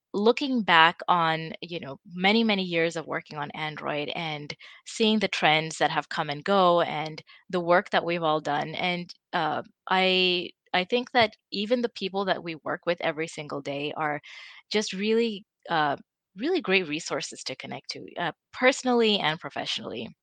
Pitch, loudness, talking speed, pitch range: 175 Hz, -26 LUFS, 170 wpm, 155-205 Hz